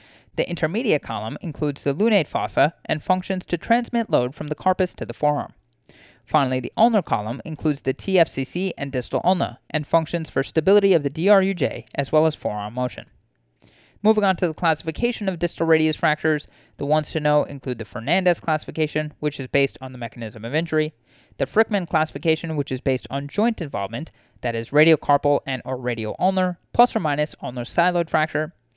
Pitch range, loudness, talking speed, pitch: 130-175 Hz, -22 LUFS, 180 wpm, 155 Hz